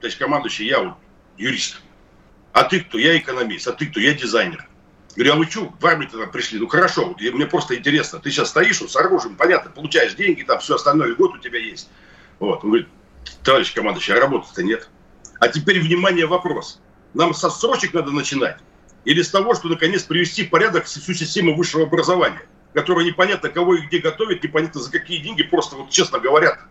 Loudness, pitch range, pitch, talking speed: -18 LUFS, 160-195 Hz, 175 Hz, 200 wpm